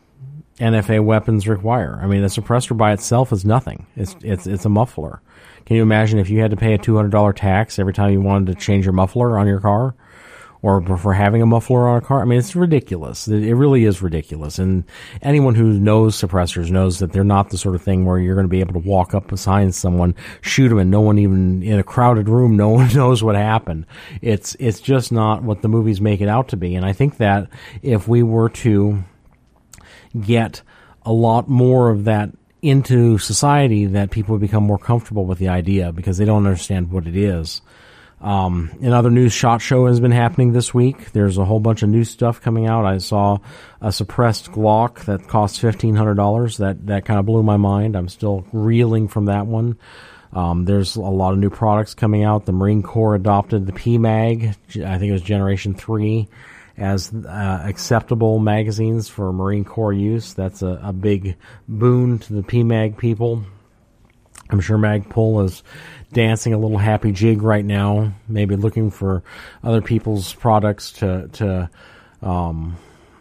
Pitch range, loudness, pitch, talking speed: 100-115 Hz, -17 LUFS, 105 Hz, 195 wpm